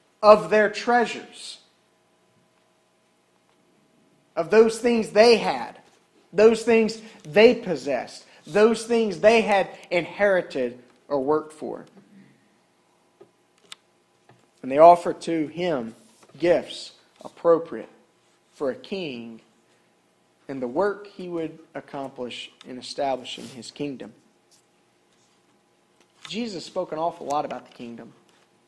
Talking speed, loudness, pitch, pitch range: 100 wpm, -22 LUFS, 170 Hz, 140-215 Hz